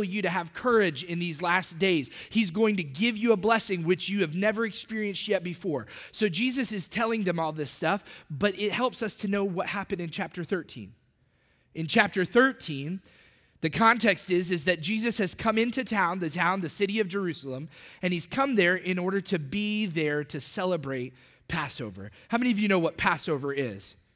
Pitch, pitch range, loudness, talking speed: 185 Hz, 165-215 Hz, -27 LUFS, 200 wpm